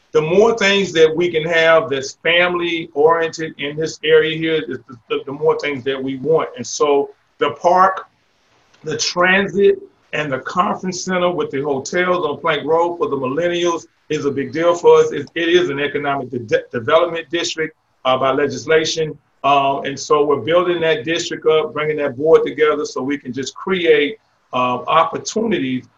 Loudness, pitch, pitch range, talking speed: -17 LUFS, 160 Hz, 145-175 Hz, 175 wpm